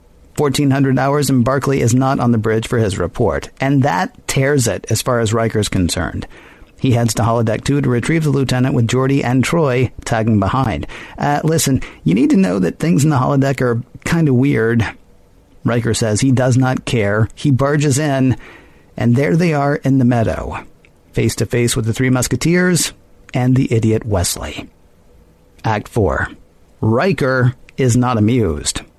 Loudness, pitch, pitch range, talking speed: -16 LUFS, 125 Hz, 110-135 Hz, 175 wpm